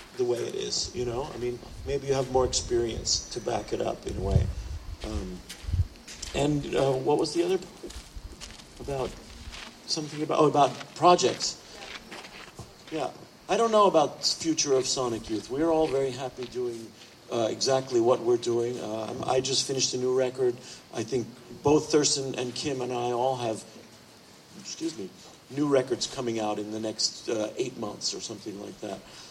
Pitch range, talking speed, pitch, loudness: 115-150 Hz, 180 wpm, 130 Hz, -28 LUFS